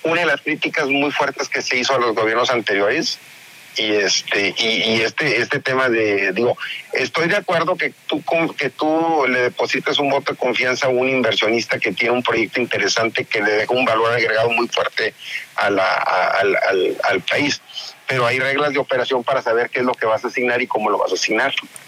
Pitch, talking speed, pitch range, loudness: 125 Hz, 215 wpm, 120-140 Hz, -18 LUFS